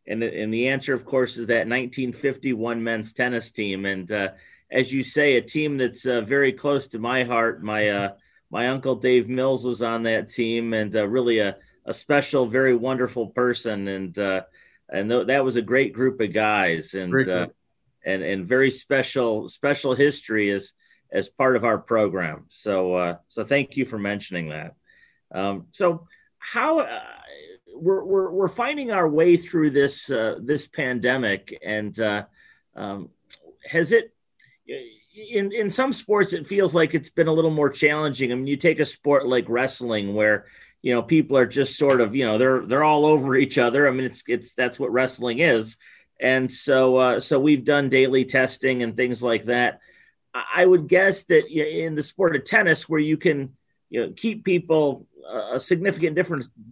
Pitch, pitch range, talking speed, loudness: 130 Hz, 115-155 Hz, 185 wpm, -22 LUFS